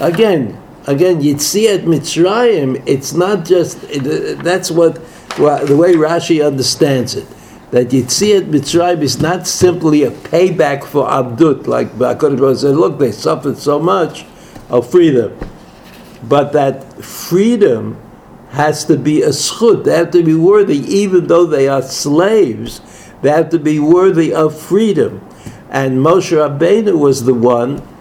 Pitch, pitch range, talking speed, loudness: 160 Hz, 140-175 Hz, 145 wpm, -12 LUFS